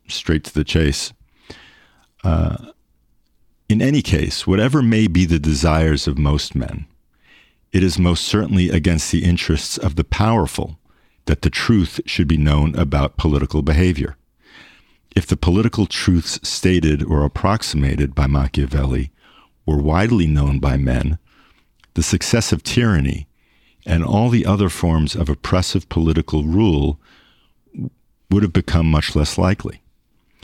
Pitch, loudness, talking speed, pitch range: 80 Hz, -18 LUFS, 135 wpm, 75-95 Hz